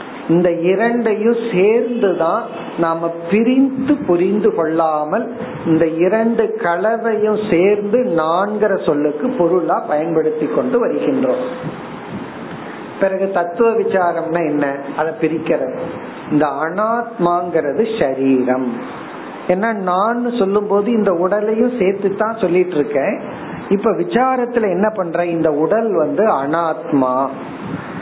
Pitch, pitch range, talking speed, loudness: 185 Hz, 165-220 Hz, 90 wpm, -17 LUFS